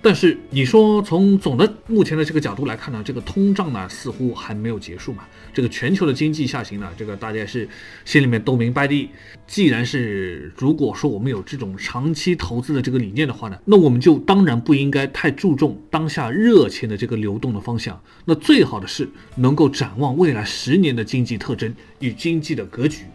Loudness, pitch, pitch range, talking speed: -19 LUFS, 135 Hz, 115-155 Hz, 320 characters per minute